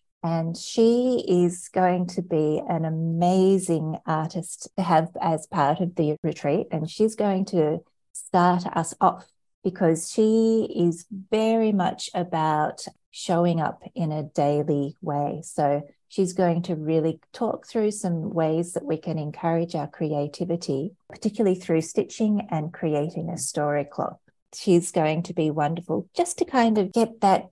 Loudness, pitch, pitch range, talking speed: -24 LUFS, 170 Hz, 160-190 Hz, 150 wpm